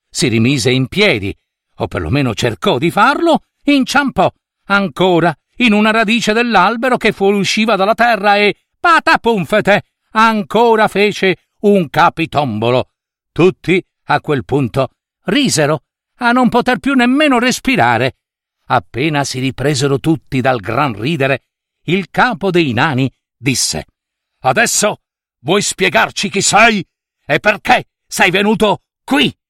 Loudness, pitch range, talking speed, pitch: -13 LUFS, 140-225 Hz, 120 wpm, 190 Hz